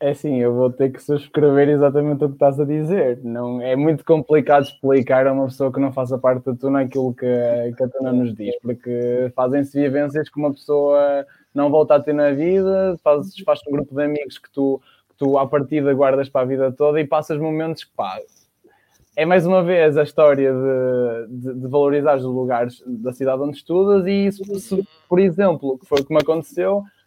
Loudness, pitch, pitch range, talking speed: -19 LUFS, 145 Hz, 130-155 Hz, 210 wpm